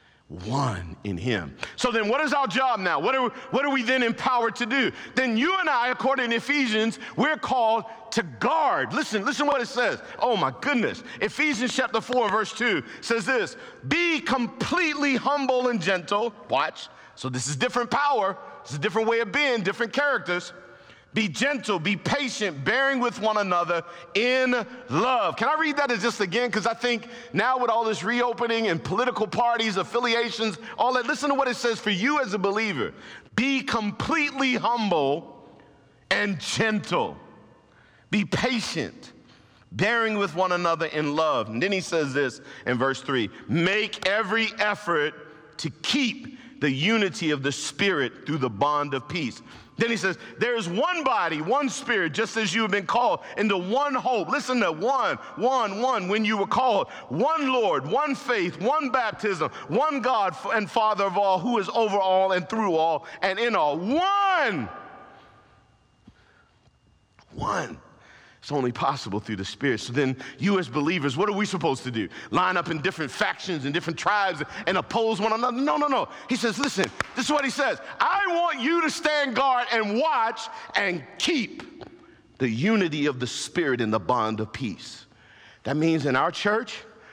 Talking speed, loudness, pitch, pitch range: 180 wpm, -25 LUFS, 225 Hz, 175-255 Hz